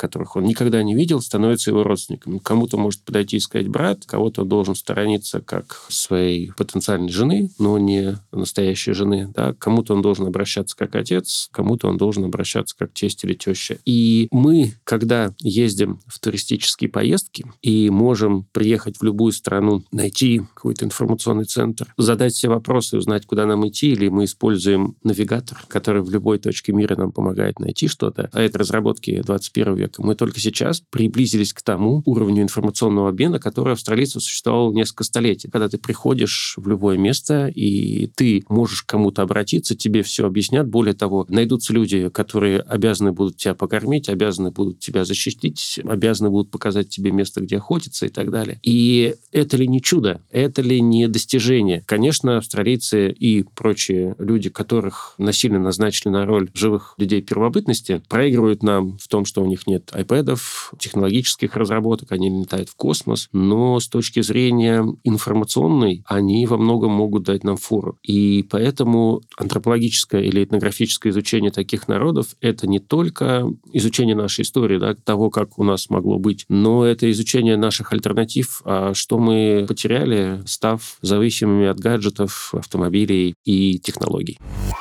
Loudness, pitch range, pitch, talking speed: -19 LUFS, 100-115 Hz, 105 Hz, 155 wpm